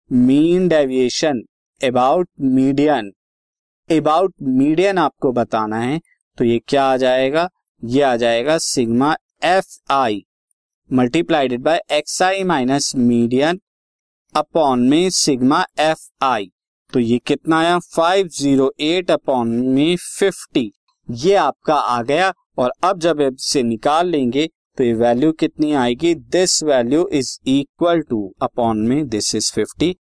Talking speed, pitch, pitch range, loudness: 130 wpm, 145 Hz, 125-170 Hz, -17 LUFS